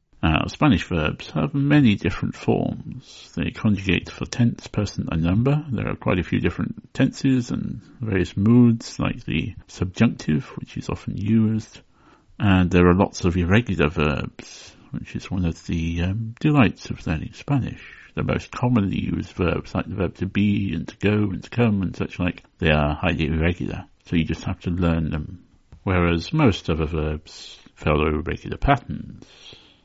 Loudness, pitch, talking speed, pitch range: -22 LUFS, 90 Hz, 170 wpm, 85-110 Hz